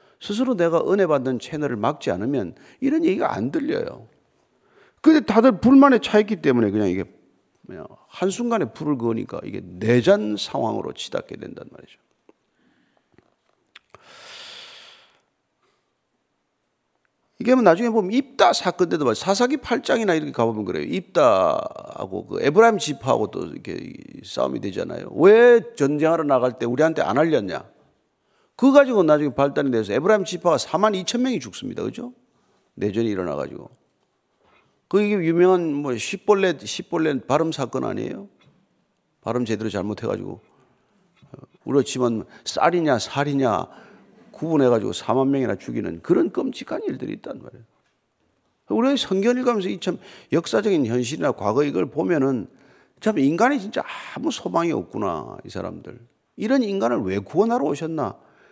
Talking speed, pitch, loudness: 315 characters per minute, 180 Hz, -21 LUFS